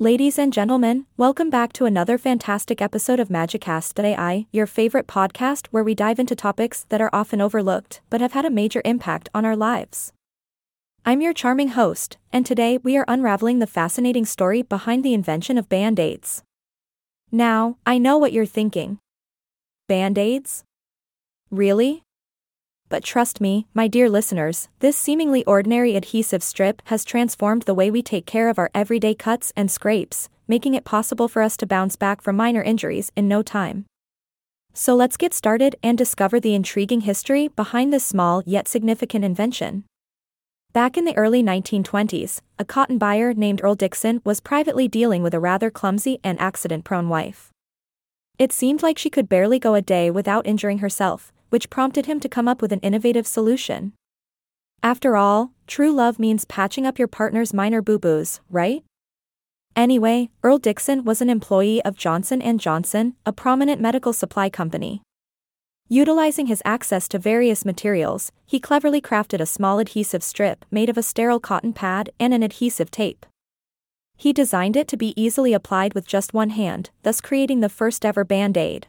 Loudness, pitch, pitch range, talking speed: -20 LUFS, 220 Hz, 200-245 Hz, 170 wpm